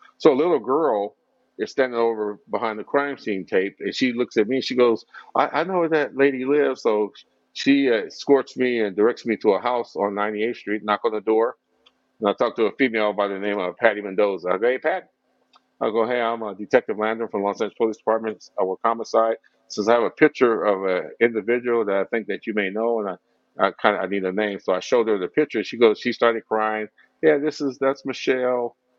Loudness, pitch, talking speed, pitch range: -22 LUFS, 115 Hz, 245 wpm, 105-130 Hz